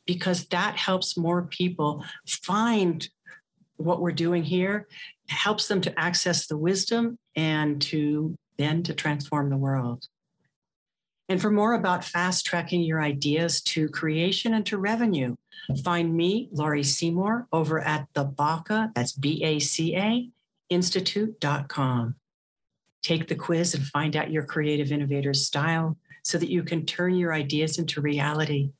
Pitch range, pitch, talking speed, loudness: 150-180 Hz, 165 Hz, 135 wpm, -26 LUFS